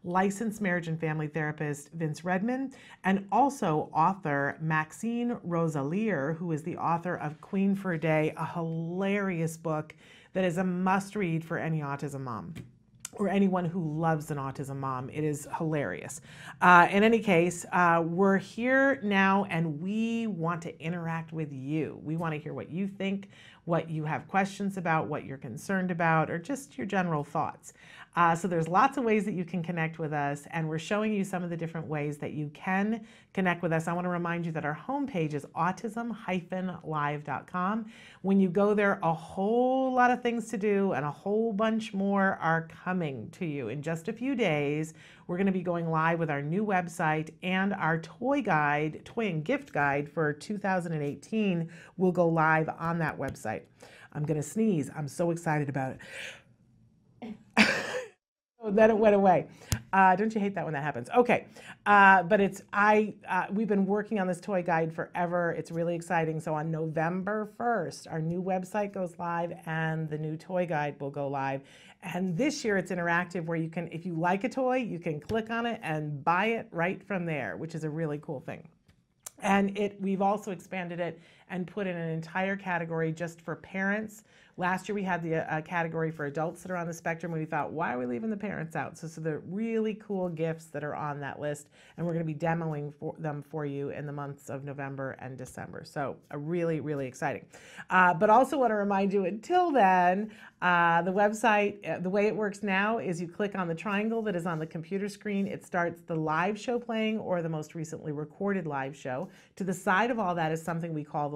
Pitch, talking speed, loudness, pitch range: 175 Hz, 205 wpm, -30 LUFS, 155-200 Hz